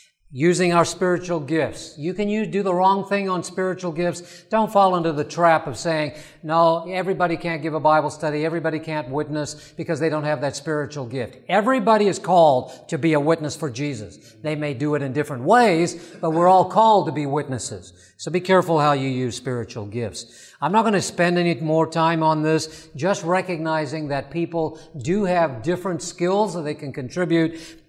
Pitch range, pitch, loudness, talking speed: 150-175 Hz, 160 Hz, -21 LUFS, 195 wpm